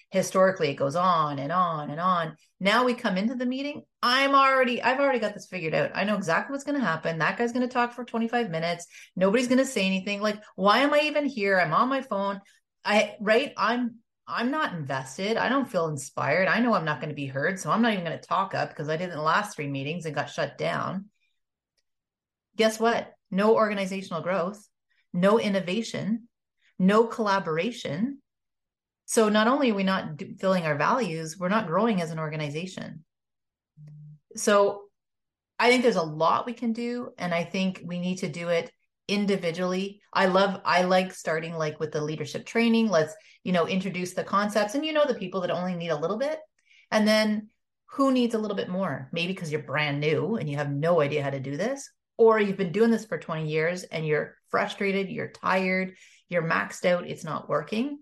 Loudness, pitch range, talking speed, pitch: -26 LUFS, 165-230 Hz, 205 wpm, 195 Hz